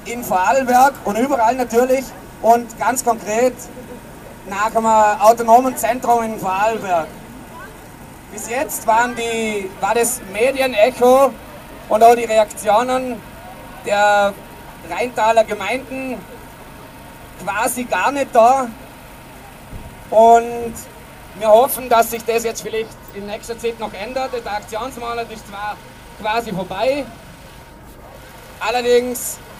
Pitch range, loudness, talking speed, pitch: 215-245 Hz, -17 LUFS, 105 wpm, 230 Hz